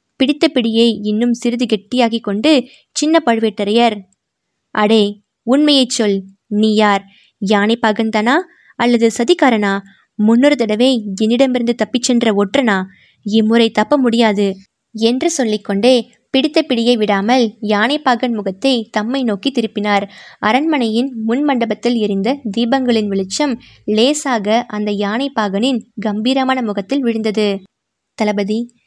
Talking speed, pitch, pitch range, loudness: 100 wpm, 230 Hz, 210-255 Hz, -15 LUFS